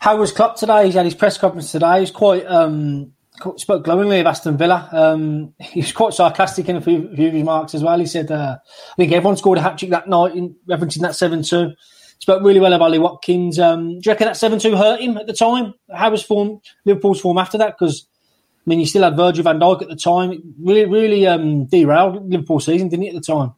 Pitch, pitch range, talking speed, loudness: 180 Hz, 165-200 Hz, 245 wpm, -16 LUFS